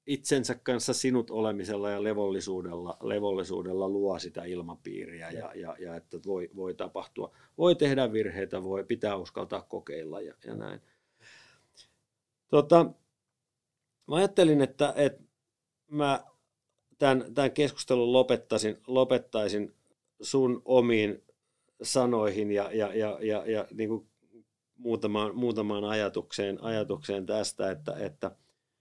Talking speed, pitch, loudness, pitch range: 115 wpm, 110 Hz, -29 LUFS, 100-130 Hz